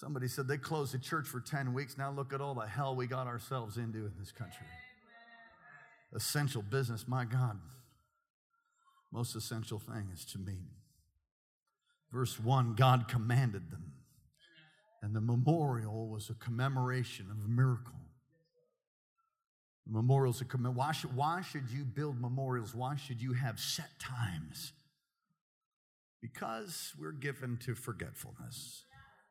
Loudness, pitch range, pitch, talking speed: -37 LUFS, 120-145 Hz, 130 Hz, 135 wpm